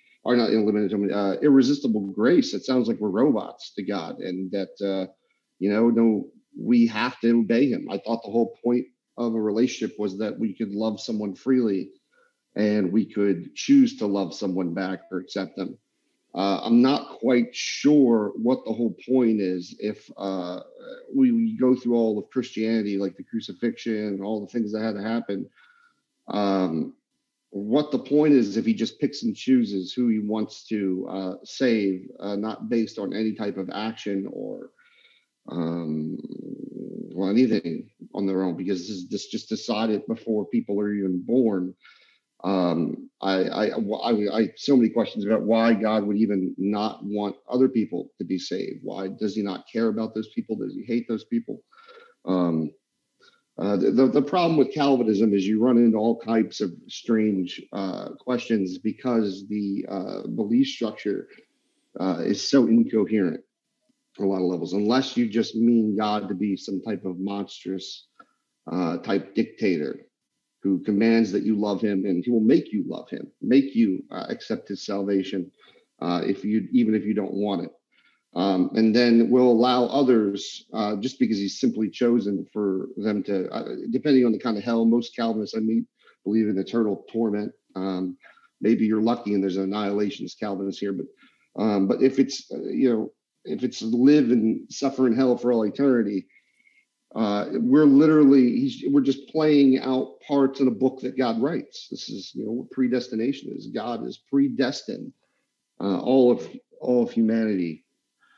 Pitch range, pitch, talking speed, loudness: 100-130 Hz, 110 Hz, 175 wpm, -24 LUFS